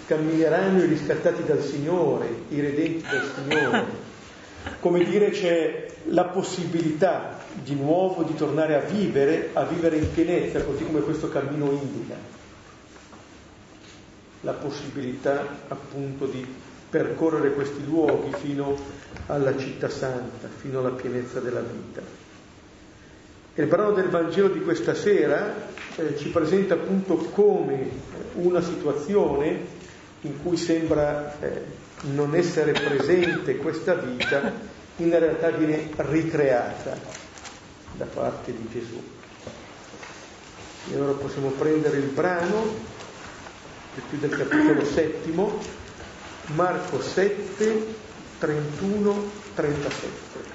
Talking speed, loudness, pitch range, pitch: 110 wpm, -25 LUFS, 140-175 Hz, 155 Hz